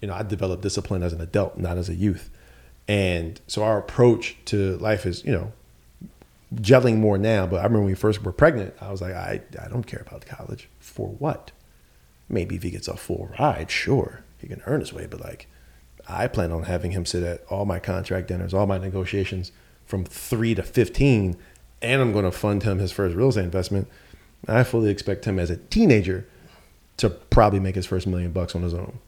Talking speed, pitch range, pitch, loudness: 215 wpm, 90-110 Hz, 95 Hz, -24 LUFS